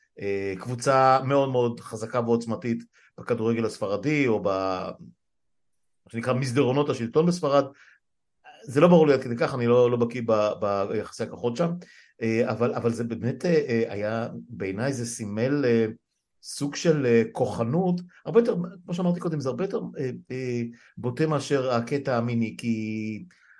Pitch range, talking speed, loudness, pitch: 115-145 Hz, 130 wpm, -25 LUFS, 120 Hz